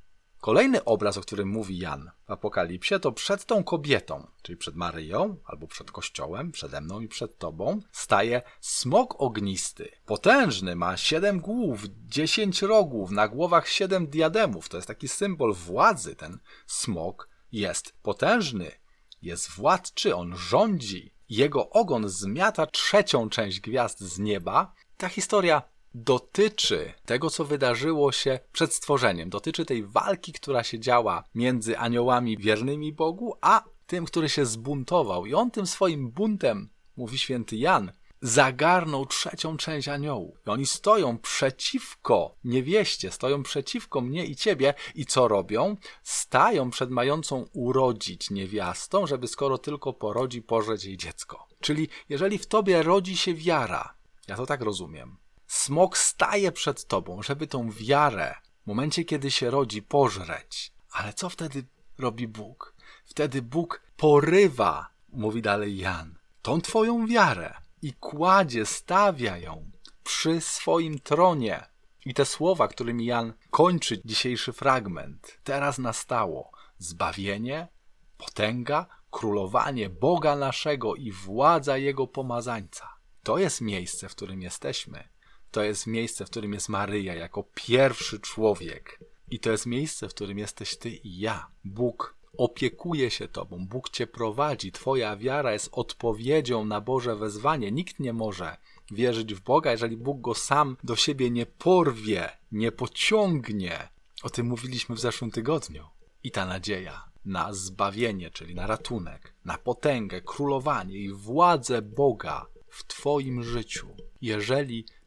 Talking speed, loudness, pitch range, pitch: 135 wpm, -26 LUFS, 110-155 Hz, 125 Hz